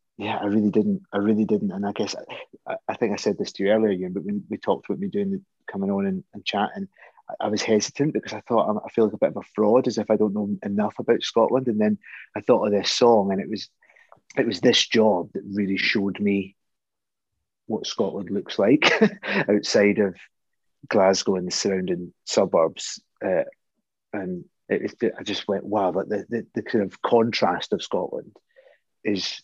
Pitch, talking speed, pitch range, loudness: 105 Hz, 210 wpm, 100-160 Hz, -23 LUFS